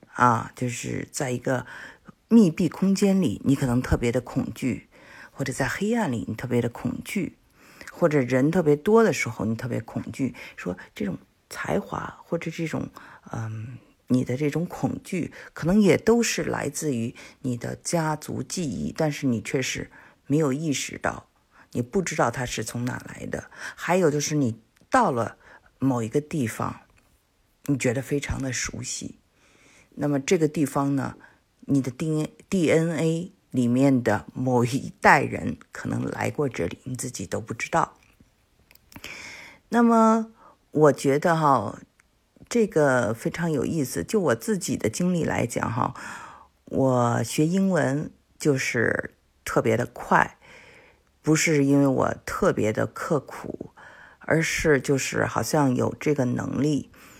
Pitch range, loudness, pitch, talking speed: 125-165 Hz, -25 LUFS, 140 Hz, 215 characters per minute